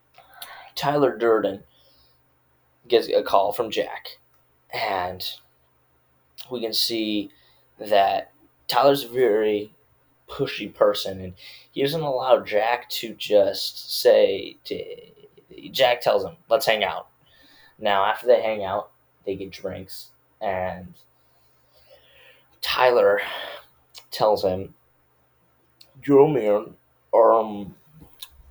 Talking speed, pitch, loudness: 100 wpm, 115 Hz, -22 LUFS